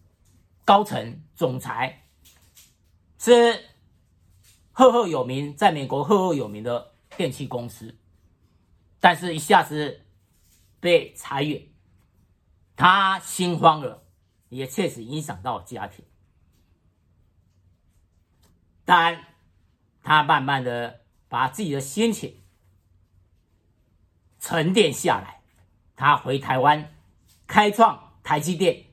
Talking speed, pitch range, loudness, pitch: 135 characters per minute, 90-150 Hz, -22 LUFS, 100 Hz